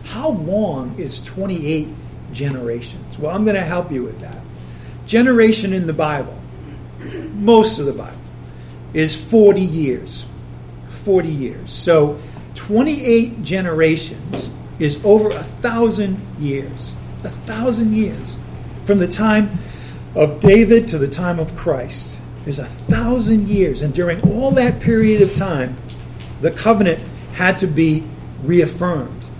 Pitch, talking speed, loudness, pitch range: 170 Hz, 130 wpm, -17 LUFS, 135-210 Hz